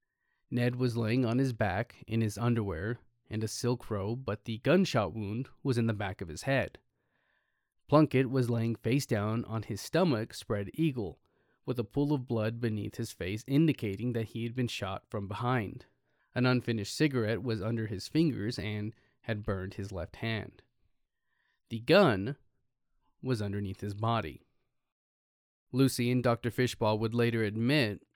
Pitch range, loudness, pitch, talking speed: 105-125 Hz, -32 LUFS, 115 Hz, 160 wpm